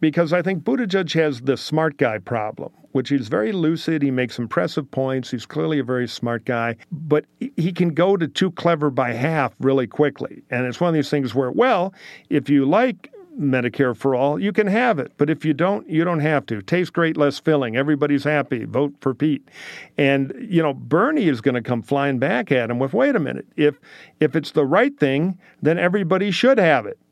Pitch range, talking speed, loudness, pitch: 135-170 Hz, 215 wpm, -20 LUFS, 150 Hz